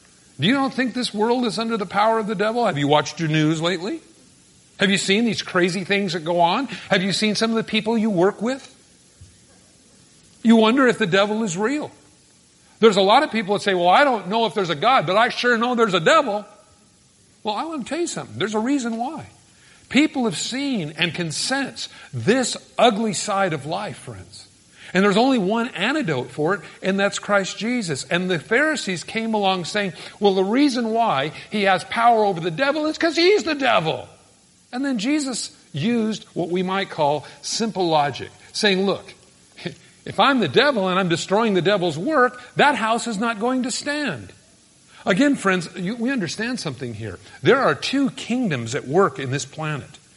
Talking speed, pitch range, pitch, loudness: 200 wpm, 180-240 Hz, 210 Hz, -20 LUFS